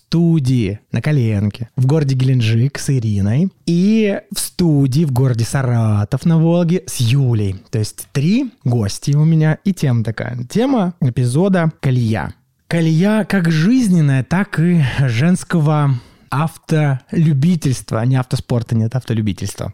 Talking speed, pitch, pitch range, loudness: 125 wpm, 140 Hz, 120-170 Hz, -16 LUFS